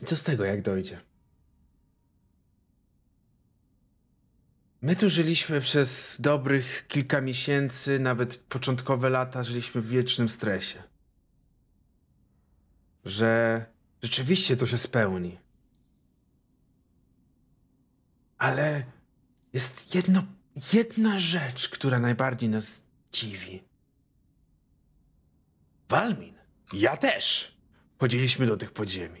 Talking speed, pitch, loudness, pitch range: 80 wpm, 125 Hz, -26 LUFS, 95-140 Hz